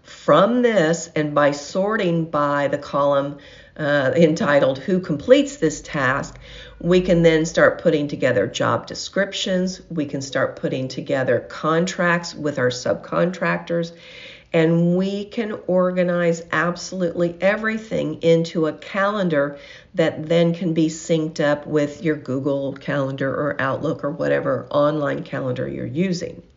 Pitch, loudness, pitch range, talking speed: 165 Hz, -20 LUFS, 145-180 Hz, 130 wpm